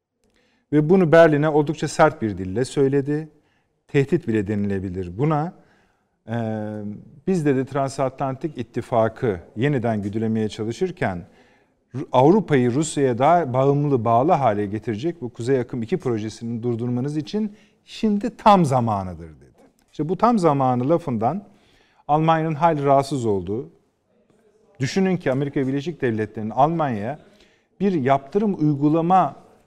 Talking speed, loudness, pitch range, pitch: 110 wpm, -21 LUFS, 115-170 Hz, 140 Hz